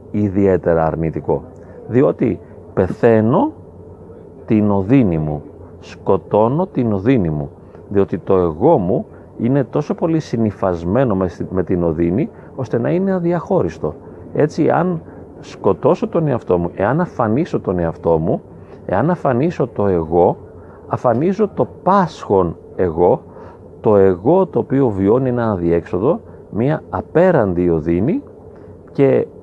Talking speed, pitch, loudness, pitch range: 115 wpm, 105 Hz, -17 LUFS, 85-135 Hz